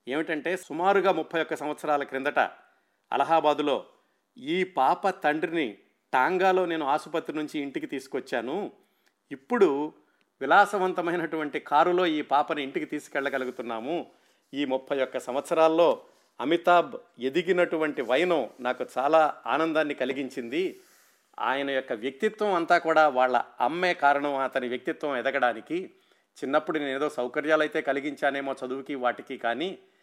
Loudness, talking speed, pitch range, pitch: -27 LUFS, 110 wpm, 135-175 Hz, 155 Hz